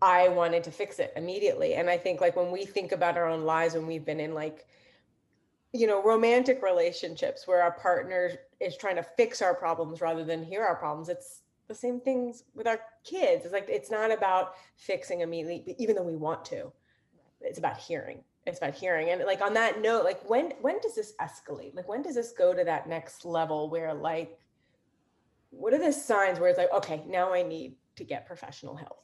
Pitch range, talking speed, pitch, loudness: 165-240 Hz, 210 wpm, 185 Hz, -29 LUFS